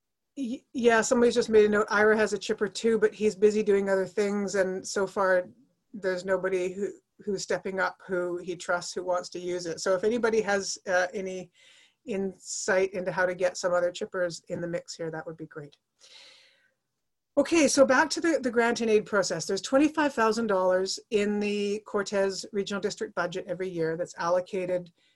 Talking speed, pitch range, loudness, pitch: 195 wpm, 180-220 Hz, -27 LUFS, 195 Hz